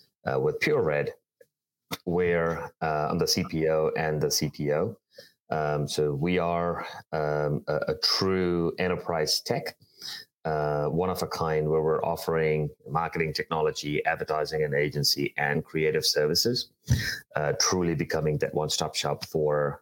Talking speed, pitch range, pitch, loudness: 135 wpm, 75-85 Hz, 80 Hz, -27 LUFS